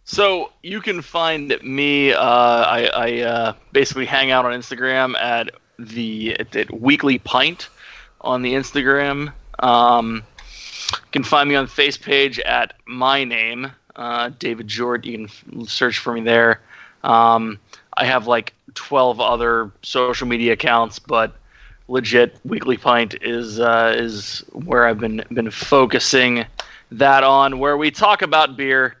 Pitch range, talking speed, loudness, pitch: 115-140 Hz, 145 wpm, -17 LUFS, 125 Hz